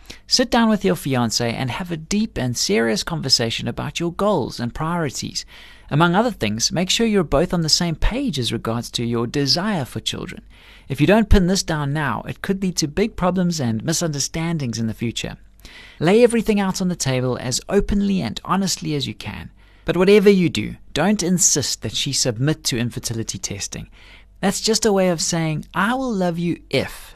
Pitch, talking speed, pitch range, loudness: 160 Hz, 200 wpm, 125-190 Hz, -20 LUFS